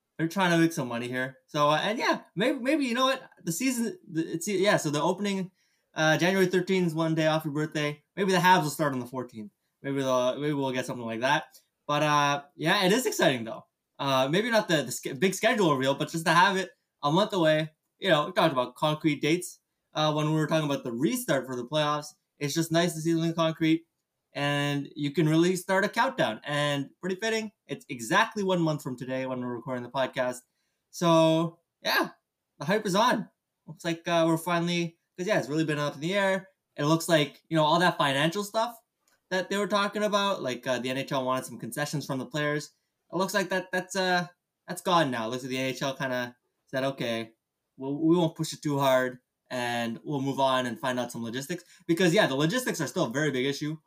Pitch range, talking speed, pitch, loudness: 135-180 Hz, 225 wpm, 155 Hz, -27 LUFS